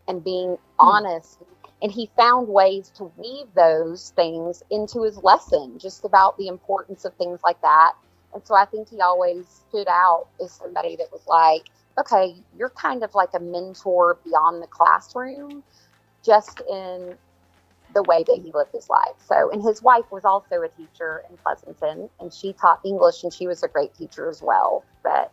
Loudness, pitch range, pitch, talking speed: -20 LUFS, 175-220 Hz, 190 Hz, 180 wpm